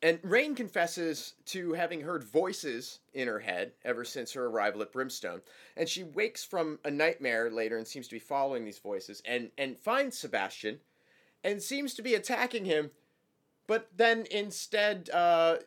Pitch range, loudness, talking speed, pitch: 130-210 Hz, -32 LUFS, 170 wpm, 165 Hz